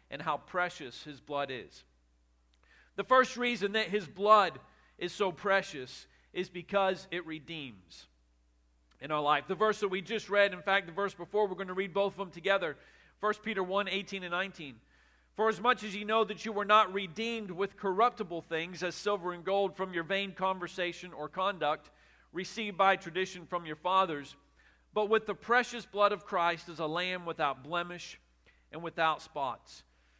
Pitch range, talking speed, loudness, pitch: 155-205 Hz, 185 wpm, -32 LUFS, 185 Hz